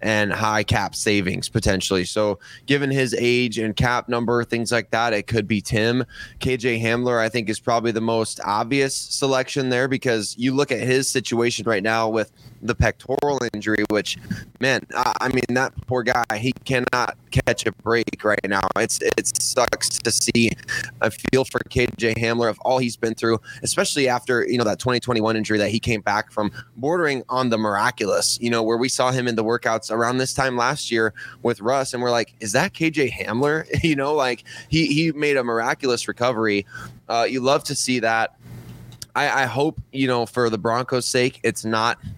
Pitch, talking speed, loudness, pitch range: 120 Hz, 195 wpm, -21 LUFS, 110-130 Hz